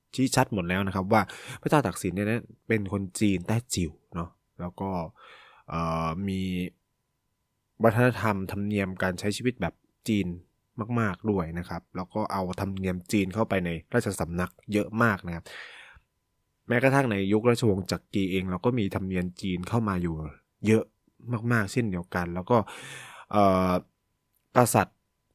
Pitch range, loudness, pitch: 90-110 Hz, -28 LUFS, 100 Hz